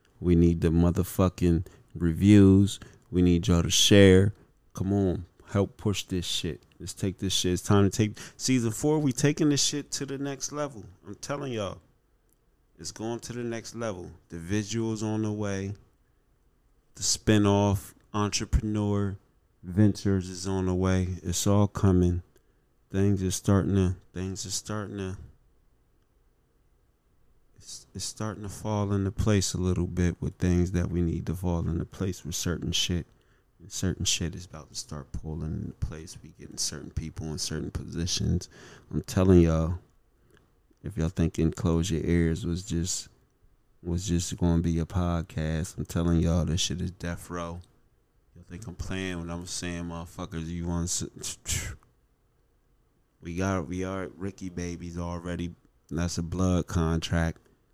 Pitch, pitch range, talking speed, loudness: 90 Hz, 85-100 Hz, 160 wpm, -28 LUFS